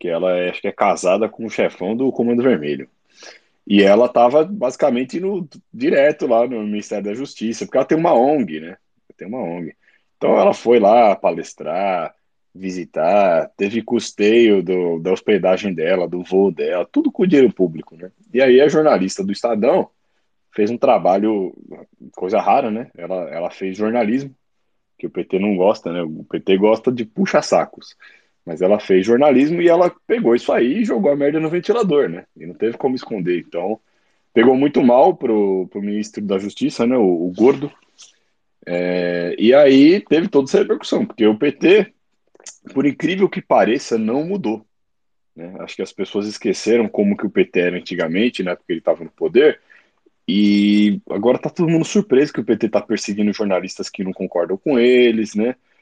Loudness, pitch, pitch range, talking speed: -17 LUFS, 110 Hz, 95-150 Hz, 180 wpm